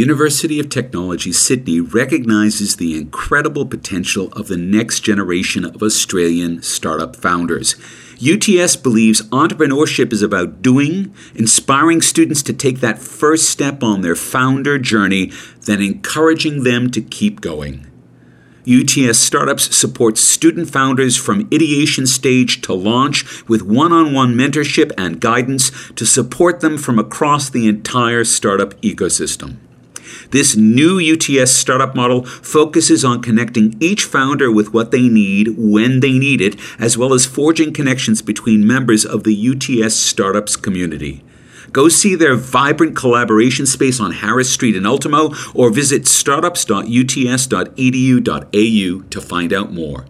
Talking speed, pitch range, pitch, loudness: 135 wpm, 110-145 Hz, 125 Hz, -13 LUFS